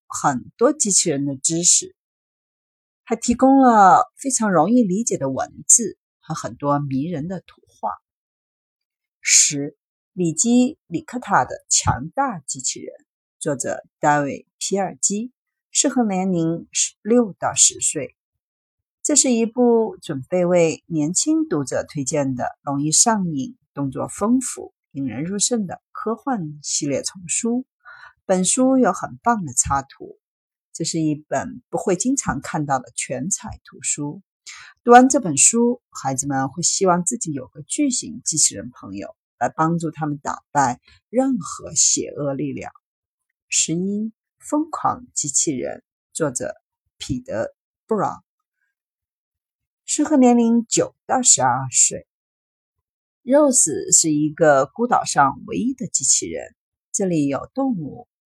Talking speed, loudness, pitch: 200 characters per minute, -19 LUFS, 185 Hz